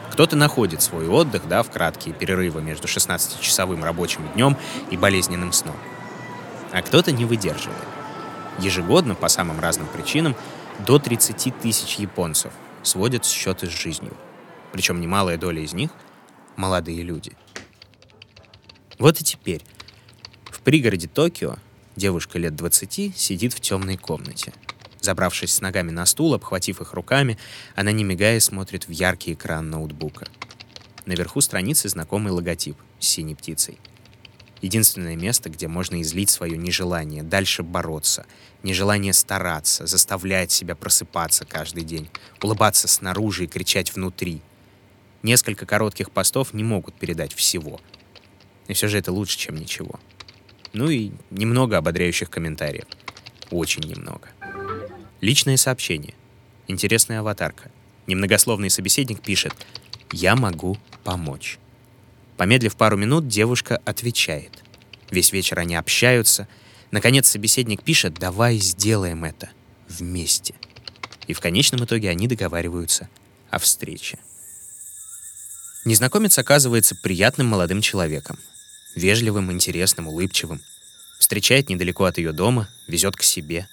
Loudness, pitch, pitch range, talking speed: -20 LUFS, 100 Hz, 90-115 Hz, 120 wpm